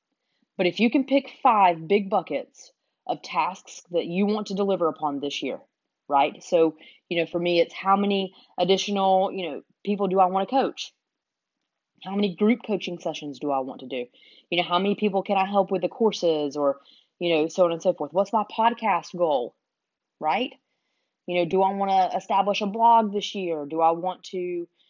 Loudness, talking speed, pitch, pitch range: -24 LUFS, 205 wpm, 190 Hz, 170-205 Hz